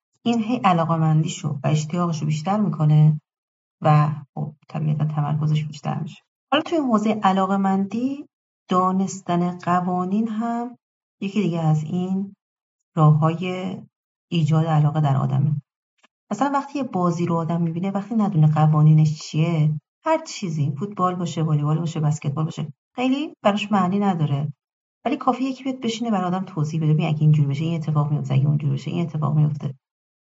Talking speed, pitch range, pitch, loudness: 155 wpm, 155-200 Hz, 170 Hz, -22 LUFS